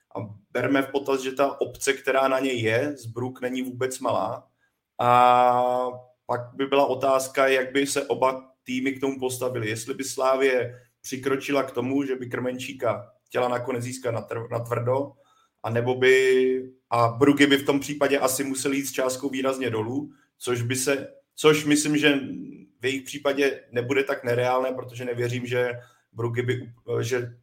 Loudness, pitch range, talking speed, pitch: -24 LUFS, 125-135 Hz, 170 wpm, 130 Hz